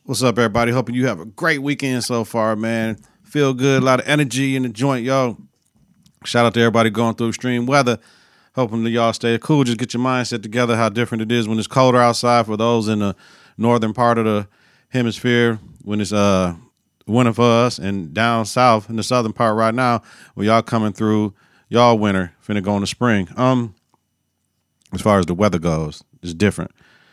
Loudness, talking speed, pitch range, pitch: -18 LUFS, 205 wpm, 110-125 Hz, 115 Hz